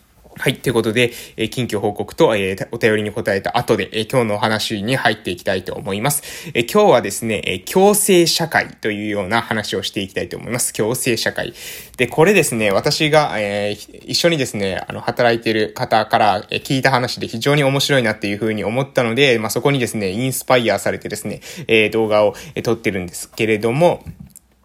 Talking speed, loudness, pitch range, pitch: 375 characters per minute, -17 LUFS, 105-135 Hz, 115 Hz